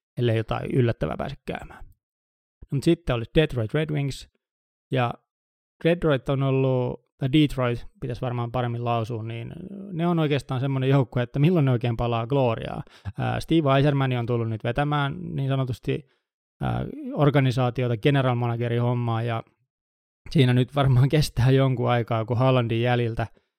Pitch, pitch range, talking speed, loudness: 125 Hz, 120-140 Hz, 140 wpm, -24 LUFS